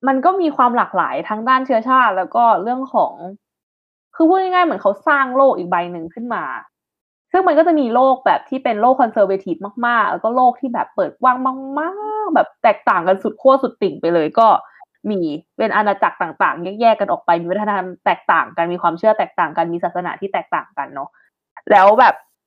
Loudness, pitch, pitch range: -16 LUFS, 235 Hz, 185-270 Hz